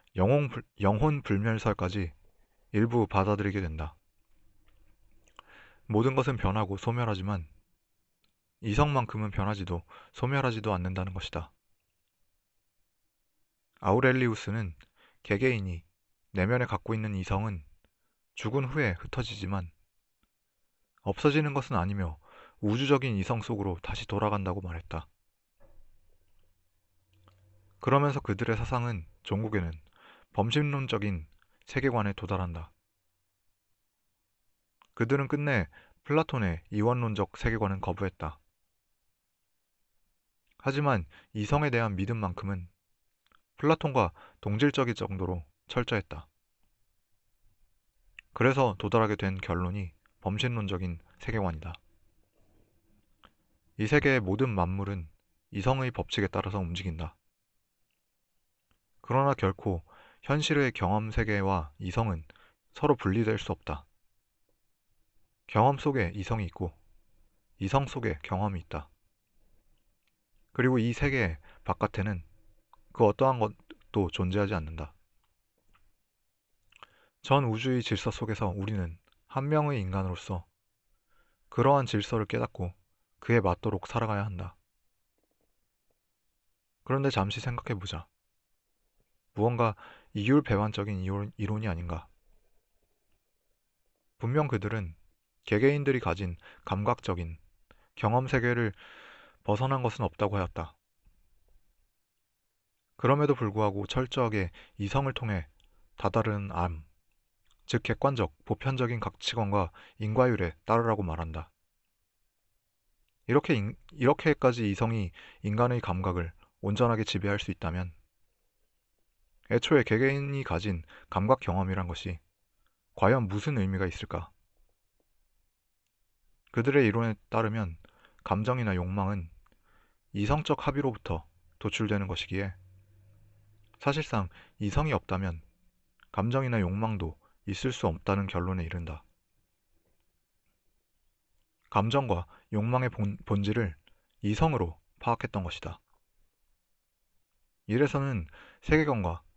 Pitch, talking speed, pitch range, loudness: 105 Hz, 235 characters per minute, 90-115 Hz, -30 LUFS